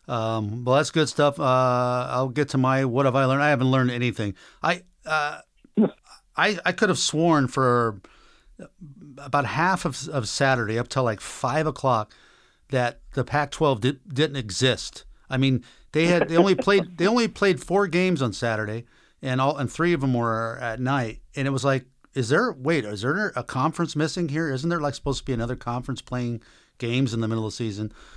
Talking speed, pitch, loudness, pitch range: 200 wpm, 135 Hz, -24 LUFS, 120-155 Hz